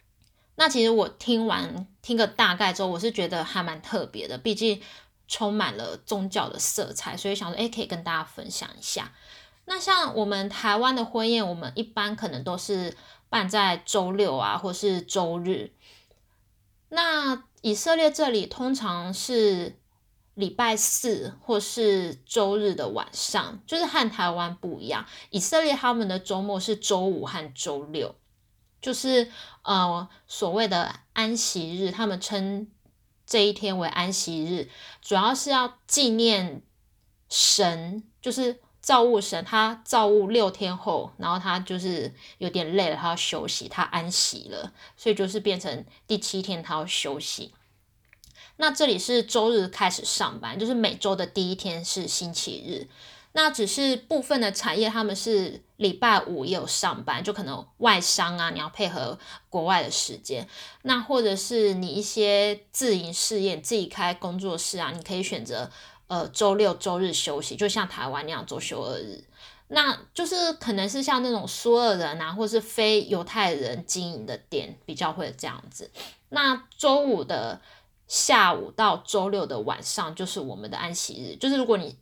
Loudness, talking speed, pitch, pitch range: -25 LUFS, 240 characters per minute, 205 Hz, 180-230 Hz